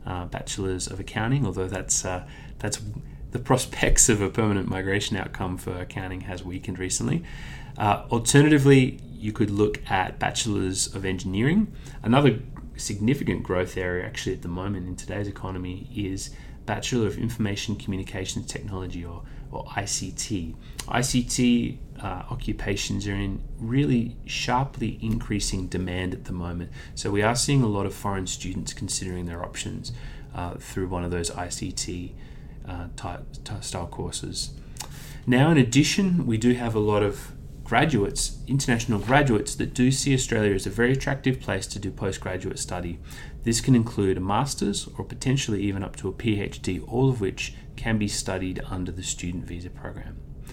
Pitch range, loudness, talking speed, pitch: 95-130 Hz, -26 LUFS, 155 wpm, 110 Hz